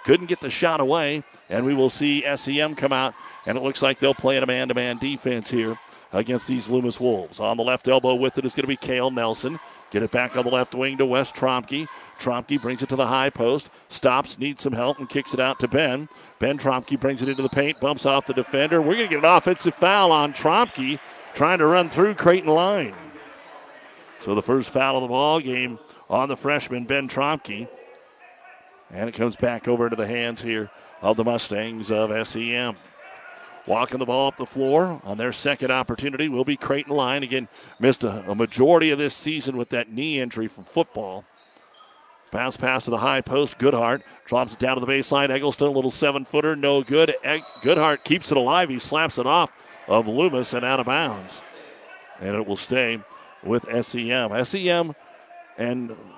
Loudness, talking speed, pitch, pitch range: -22 LUFS, 200 wpm, 130 Hz, 120-145 Hz